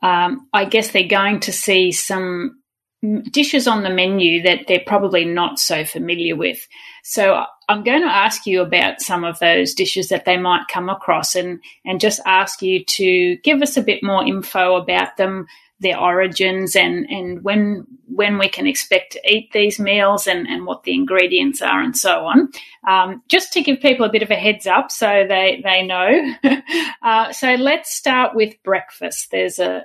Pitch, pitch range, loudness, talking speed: 200 Hz, 185-260 Hz, -16 LUFS, 190 wpm